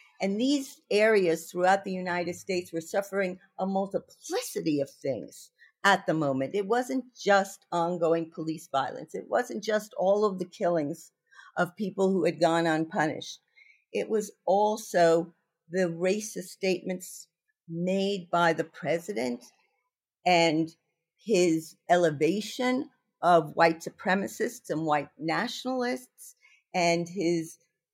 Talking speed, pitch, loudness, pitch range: 120 wpm, 180 Hz, -28 LUFS, 165-210 Hz